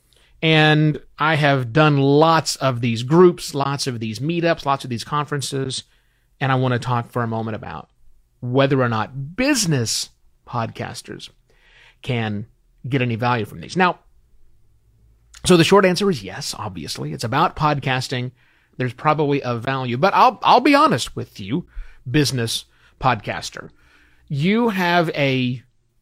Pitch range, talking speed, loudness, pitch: 120-155 Hz, 145 wpm, -19 LUFS, 130 Hz